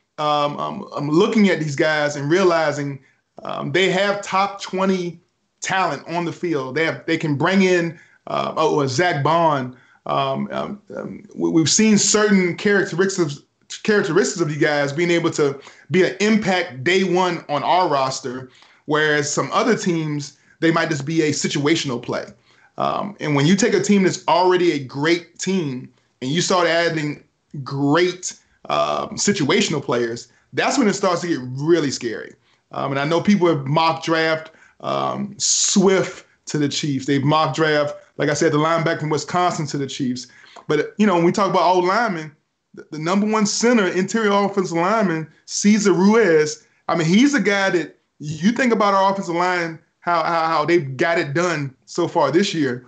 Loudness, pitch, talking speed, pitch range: -19 LUFS, 165 Hz, 180 wpm, 150-185 Hz